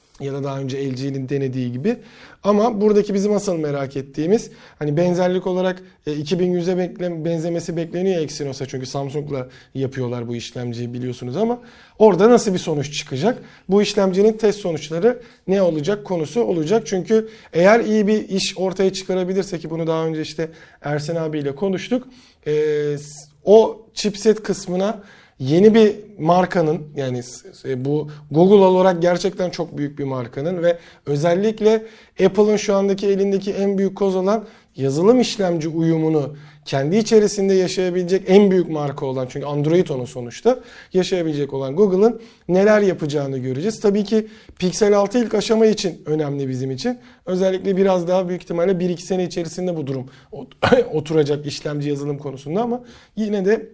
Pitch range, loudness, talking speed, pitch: 150-205 Hz, -19 LUFS, 145 wpm, 180 Hz